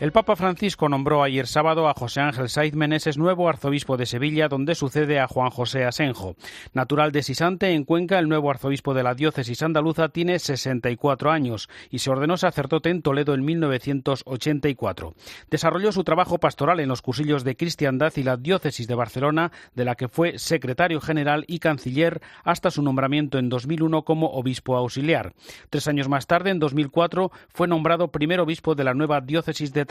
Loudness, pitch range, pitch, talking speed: -23 LUFS, 135-165 Hz, 150 Hz, 180 wpm